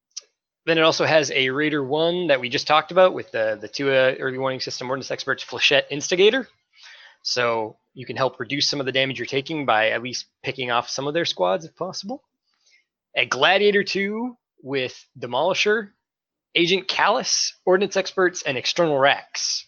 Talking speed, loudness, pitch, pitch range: 175 wpm, -21 LUFS, 150 Hz, 130-185 Hz